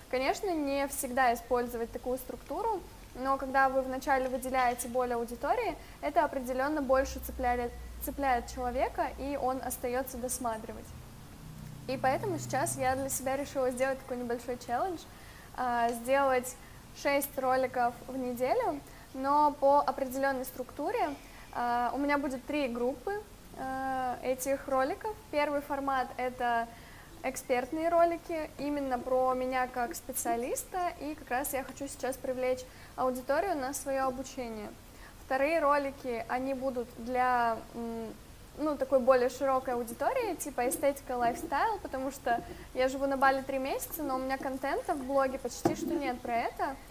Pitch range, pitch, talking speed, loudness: 250-280 Hz, 265 Hz, 130 wpm, -32 LUFS